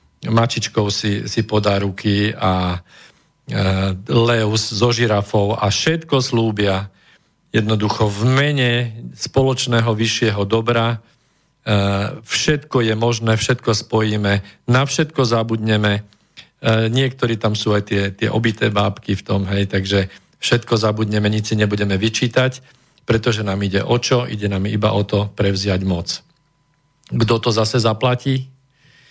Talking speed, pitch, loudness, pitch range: 130 wpm, 110 Hz, -18 LUFS, 100-120 Hz